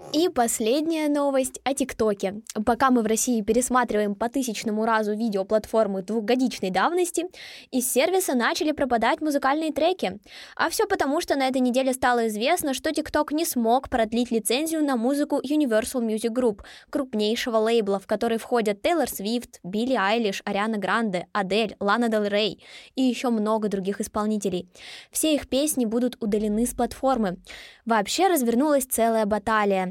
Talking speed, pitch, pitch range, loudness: 145 wpm, 240 Hz, 215-275 Hz, -24 LUFS